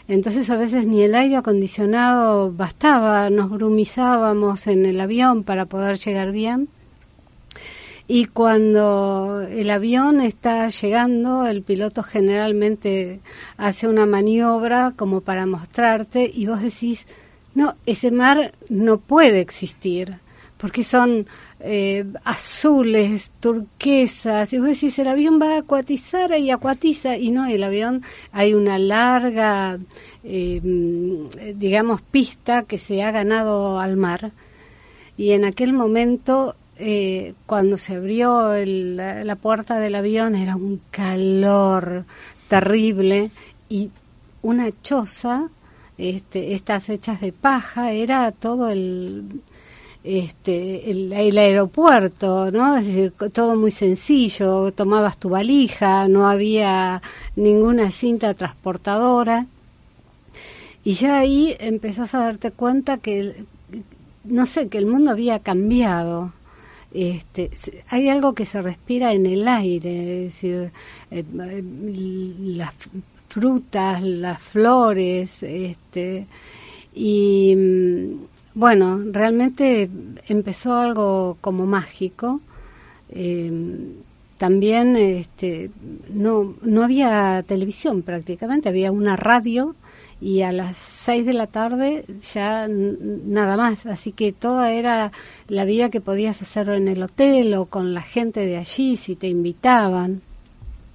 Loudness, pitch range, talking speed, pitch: -19 LUFS, 190-235 Hz, 120 wpm, 210 Hz